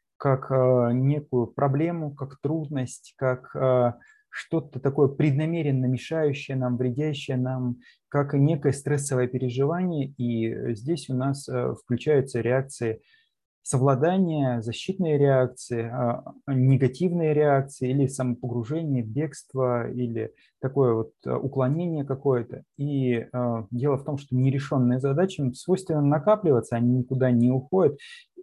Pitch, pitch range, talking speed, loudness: 135 Hz, 125-150 Hz, 105 wpm, -25 LUFS